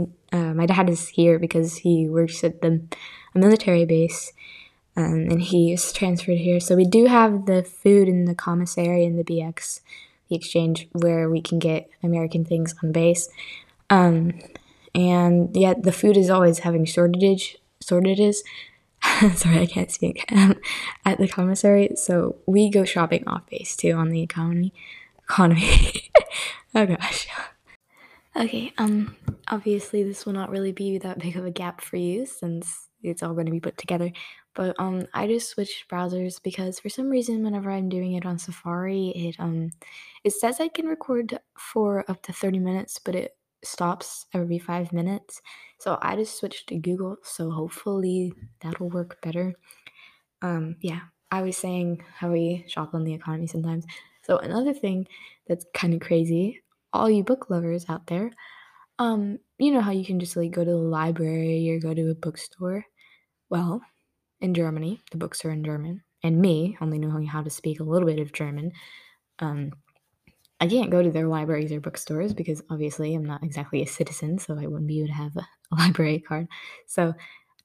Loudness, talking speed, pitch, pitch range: -23 LUFS, 180 wpm, 175 Hz, 165-195 Hz